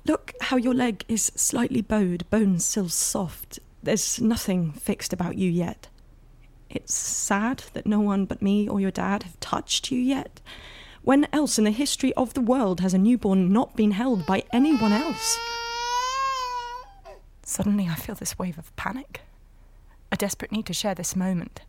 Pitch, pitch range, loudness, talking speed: 220 Hz, 195-265 Hz, -25 LUFS, 170 wpm